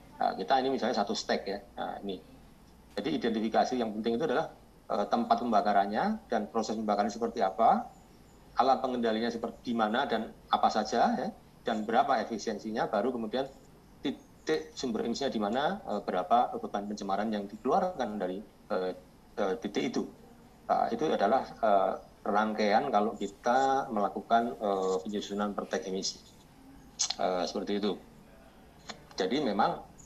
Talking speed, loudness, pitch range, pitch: 140 wpm, -31 LUFS, 105-125 Hz, 110 Hz